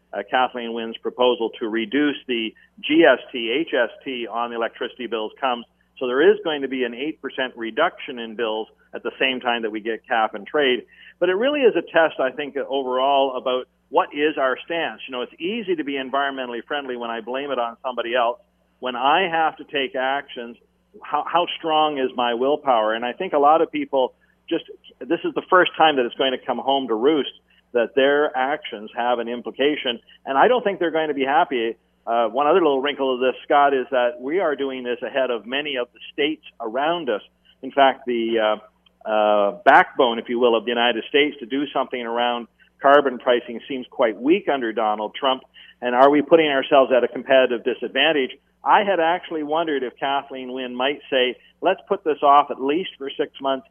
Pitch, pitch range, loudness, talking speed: 130 Hz, 120-145 Hz, -21 LUFS, 210 wpm